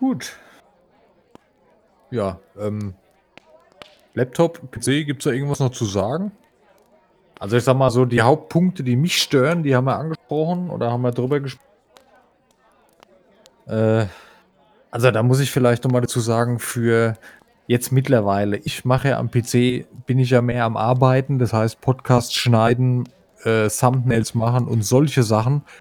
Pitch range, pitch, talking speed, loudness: 115-135 Hz, 125 Hz, 145 wpm, -19 LUFS